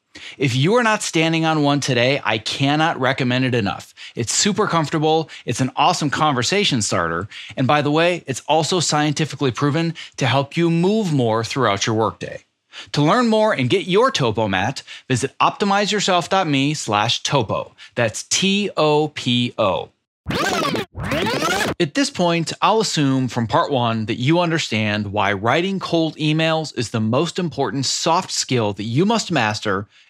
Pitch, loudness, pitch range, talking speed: 145 Hz, -19 LUFS, 120-165 Hz, 155 wpm